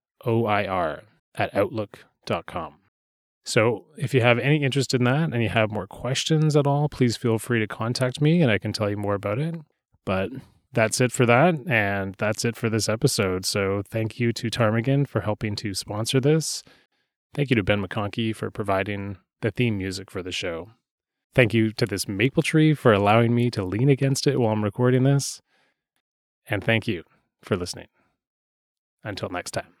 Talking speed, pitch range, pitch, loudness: 185 wpm, 105-135 Hz, 115 Hz, -23 LUFS